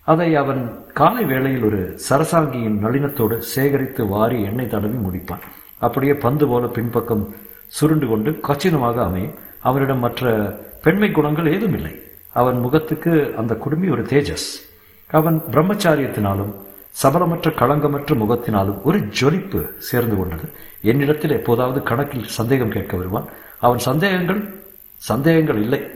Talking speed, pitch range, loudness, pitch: 120 wpm, 110-150 Hz, -19 LUFS, 130 Hz